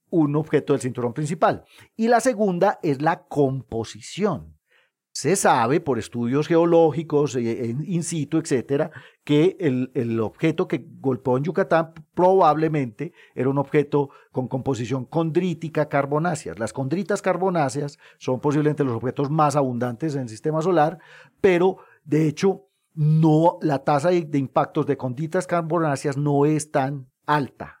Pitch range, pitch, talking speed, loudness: 135-165 Hz, 150 Hz, 140 wpm, -22 LUFS